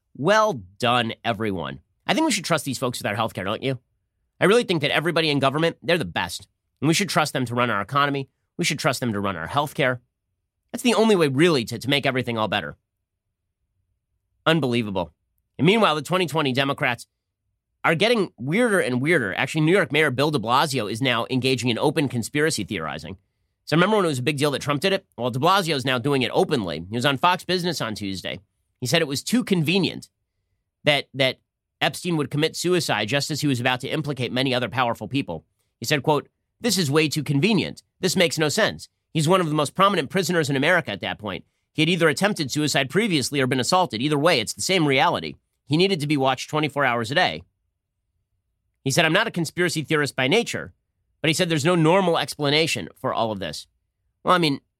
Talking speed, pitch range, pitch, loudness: 220 wpm, 105-160 Hz, 135 Hz, -22 LUFS